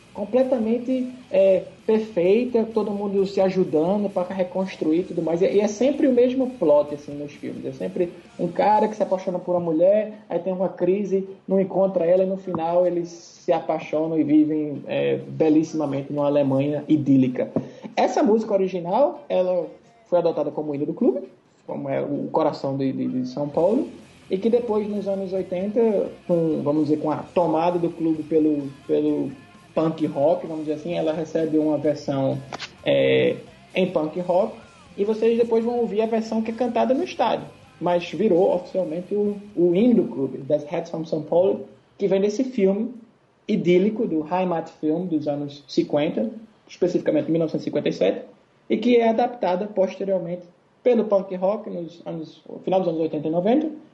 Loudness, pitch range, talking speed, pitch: -22 LUFS, 155-205 Hz, 170 wpm, 180 Hz